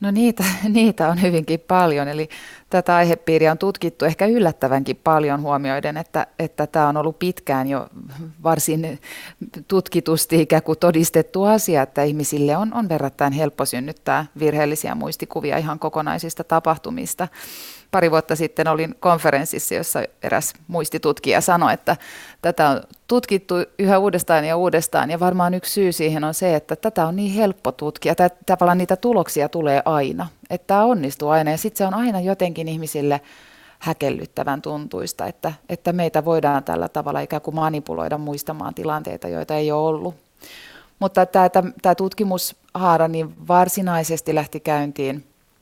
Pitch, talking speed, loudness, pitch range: 160 Hz, 145 wpm, -20 LUFS, 150-180 Hz